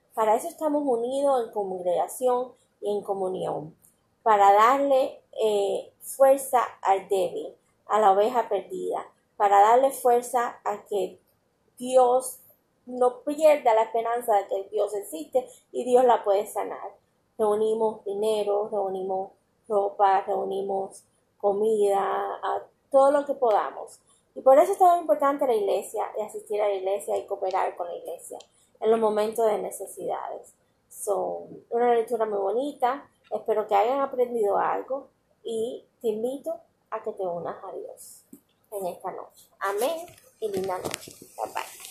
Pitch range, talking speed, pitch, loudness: 205-265 Hz, 140 wpm, 225 Hz, -25 LUFS